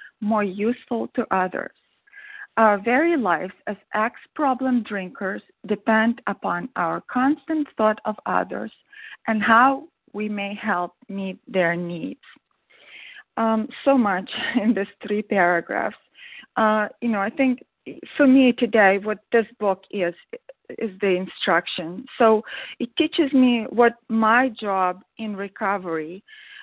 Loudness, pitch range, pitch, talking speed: -22 LUFS, 200-255 Hz, 220 Hz, 125 wpm